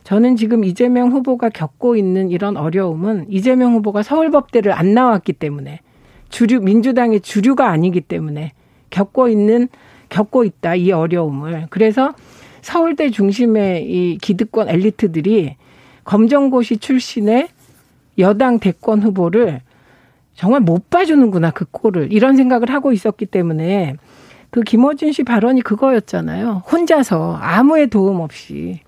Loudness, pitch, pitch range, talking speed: -15 LUFS, 215 Hz, 175-245 Hz, 305 characters per minute